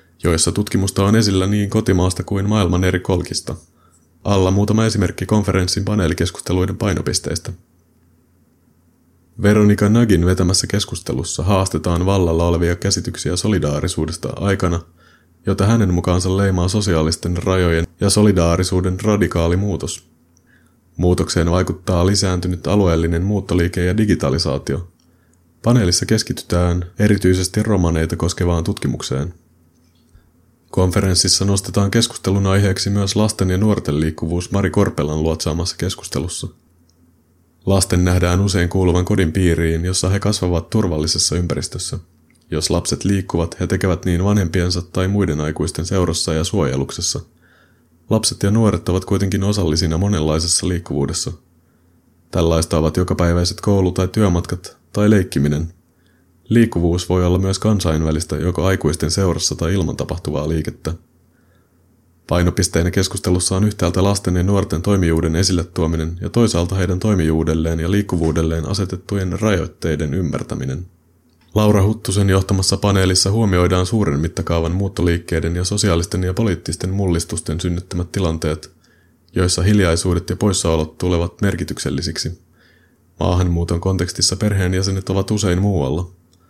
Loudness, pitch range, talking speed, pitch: -18 LUFS, 85-100 Hz, 110 wpm, 90 Hz